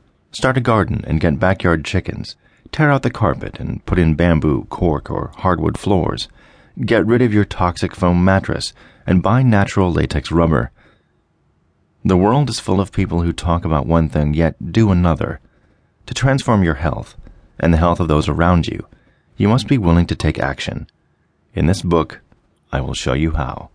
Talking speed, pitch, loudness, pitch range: 180 wpm, 90 Hz, -17 LUFS, 80-110 Hz